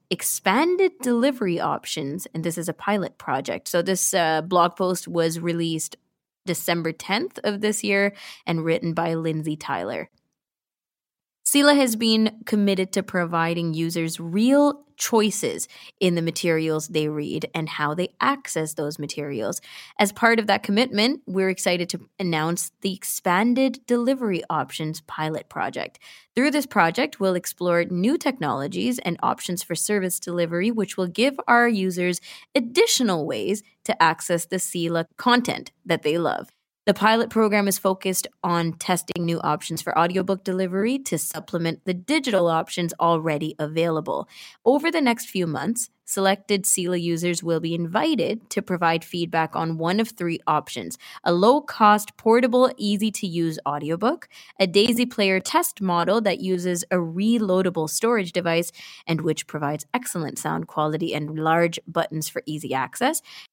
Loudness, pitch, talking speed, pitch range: -23 LUFS, 185 Hz, 150 wpm, 165-220 Hz